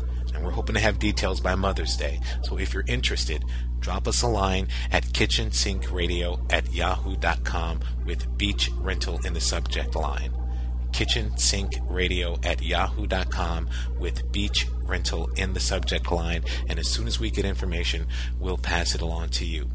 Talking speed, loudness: 160 wpm, -26 LUFS